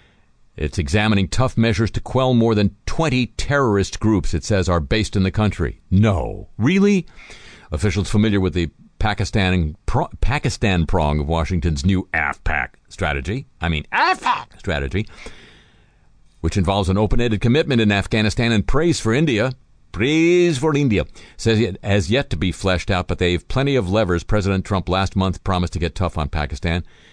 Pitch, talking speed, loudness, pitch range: 100 Hz, 165 wpm, -20 LUFS, 90-115 Hz